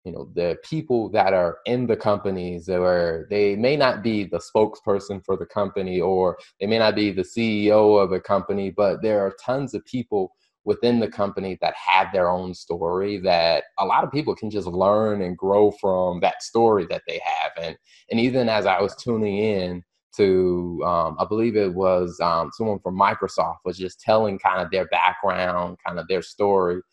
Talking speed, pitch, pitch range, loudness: 195 wpm, 100 Hz, 90-110 Hz, -22 LUFS